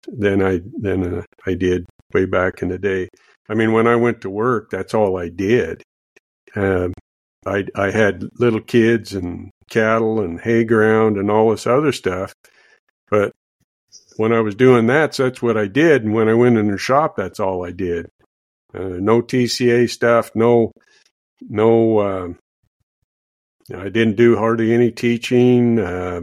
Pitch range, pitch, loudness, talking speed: 95-115 Hz, 110 Hz, -17 LUFS, 180 wpm